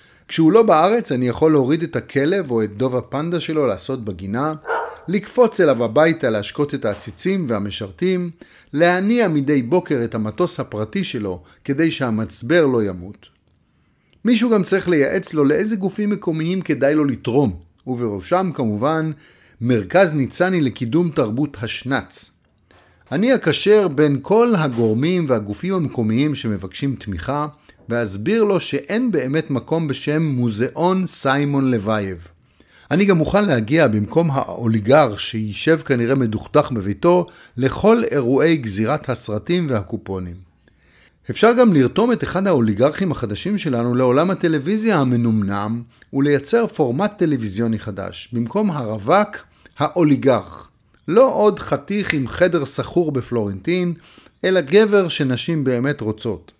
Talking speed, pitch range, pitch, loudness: 120 wpm, 115-175 Hz, 140 Hz, -19 LUFS